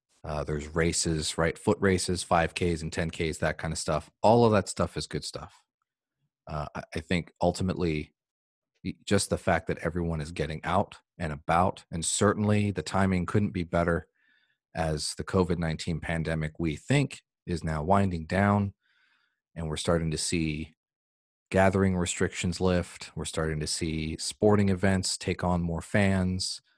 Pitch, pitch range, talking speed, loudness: 85 Hz, 80-95 Hz, 155 wpm, -28 LUFS